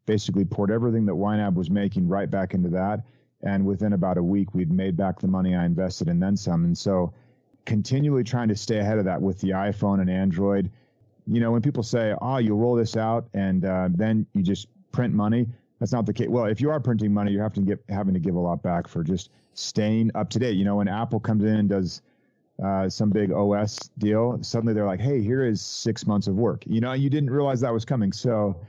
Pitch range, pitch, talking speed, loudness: 100-120 Hz, 105 Hz, 235 wpm, -24 LUFS